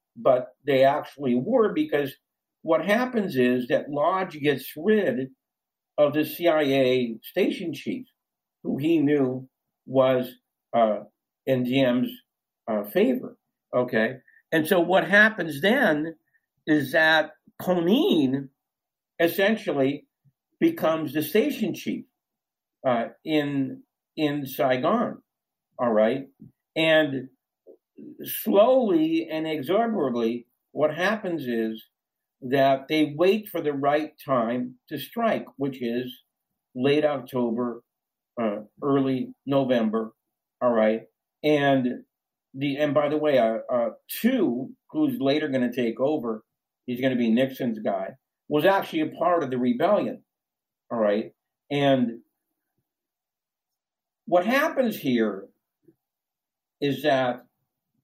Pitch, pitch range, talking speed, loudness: 145 Hz, 125-175 Hz, 110 wpm, -24 LUFS